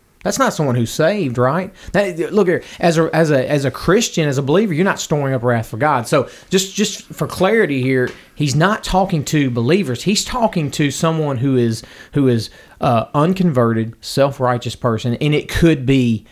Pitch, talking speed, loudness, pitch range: 150 Hz, 200 wpm, -17 LUFS, 125-175 Hz